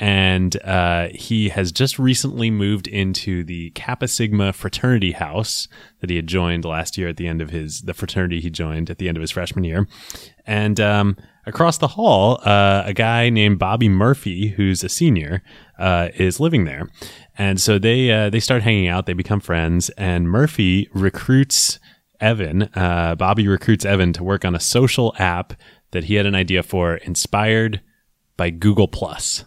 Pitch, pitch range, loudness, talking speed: 95 Hz, 90-110 Hz, -18 LUFS, 180 wpm